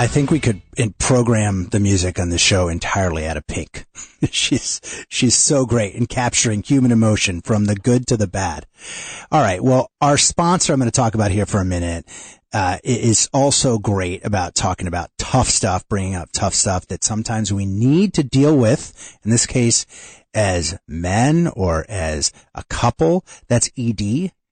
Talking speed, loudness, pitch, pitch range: 180 wpm, -18 LUFS, 105 Hz, 95-125 Hz